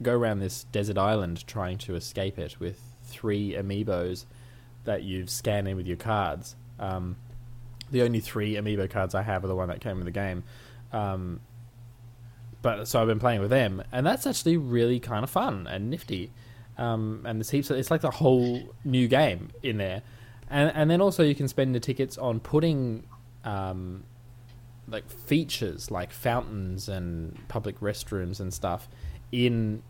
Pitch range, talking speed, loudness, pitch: 100-120 Hz, 175 wpm, -28 LUFS, 115 Hz